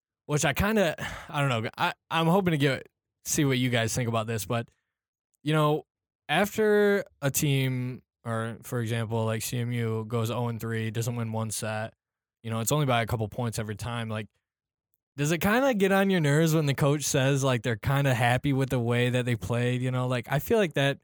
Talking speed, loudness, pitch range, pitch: 225 wpm, -27 LUFS, 115-145 Hz, 125 Hz